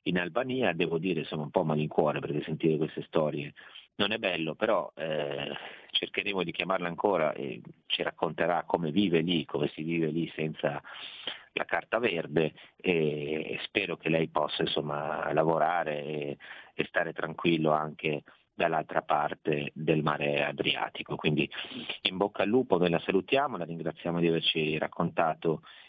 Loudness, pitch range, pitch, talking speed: -30 LUFS, 75-85 Hz, 80 Hz, 150 wpm